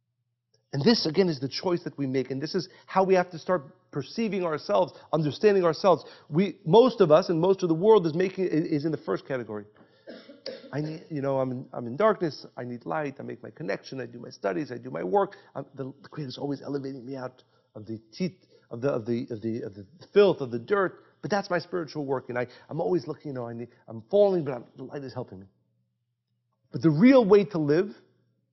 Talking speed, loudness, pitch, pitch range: 245 wpm, -26 LUFS, 145 Hz, 120-180 Hz